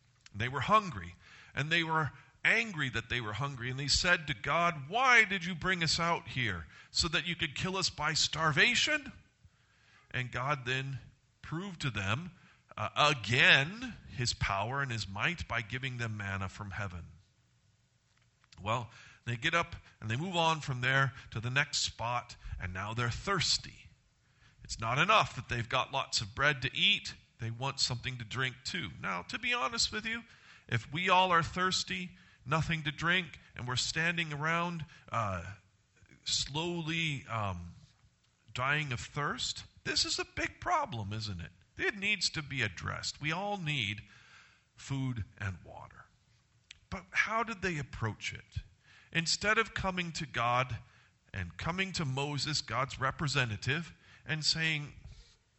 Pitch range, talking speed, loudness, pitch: 115-165 Hz, 160 wpm, -32 LUFS, 130 Hz